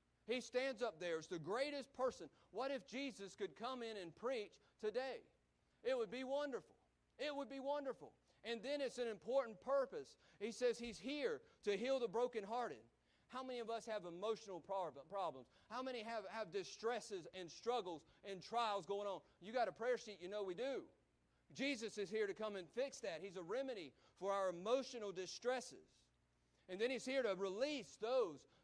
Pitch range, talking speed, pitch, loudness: 195-260 Hz, 185 wpm, 230 Hz, -46 LUFS